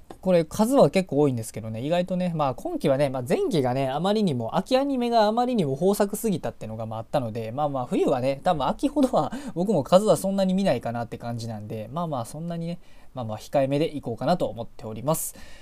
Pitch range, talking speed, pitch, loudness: 120-195 Hz, 490 characters per minute, 150 Hz, -25 LUFS